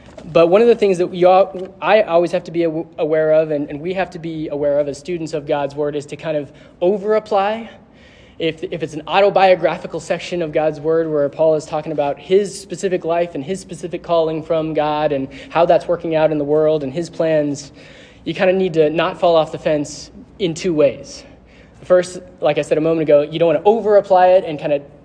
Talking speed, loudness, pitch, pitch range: 230 wpm, -17 LUFS, 165 Hz, 150-185 Hz